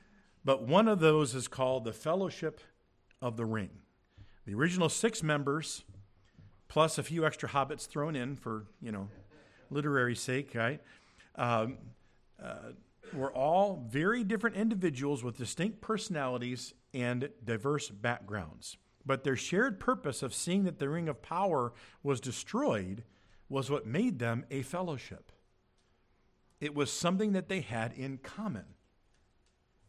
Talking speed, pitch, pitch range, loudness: 135 wpm, 135 Hz, 115-160 Hz, -34 LUFS